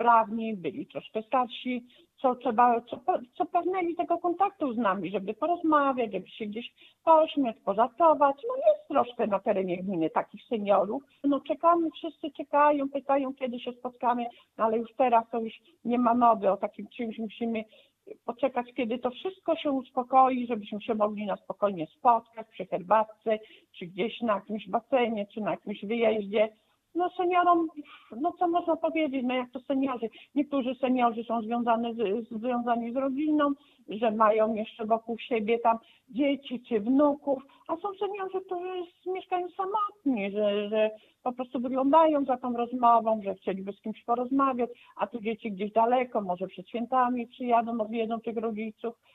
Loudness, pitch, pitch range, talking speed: -28 LUFS, 240 Hz, 225-285 Hz, 160 wpm